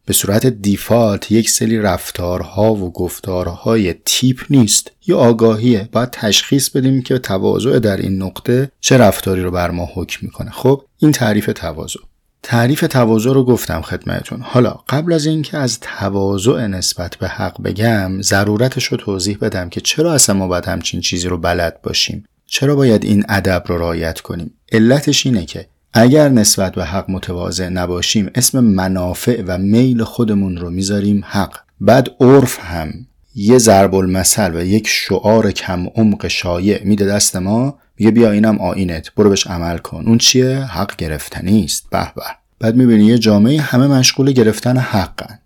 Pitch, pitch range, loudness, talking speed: 105 Hz, 95-120 Hz, -14 LUFS, 160 wpm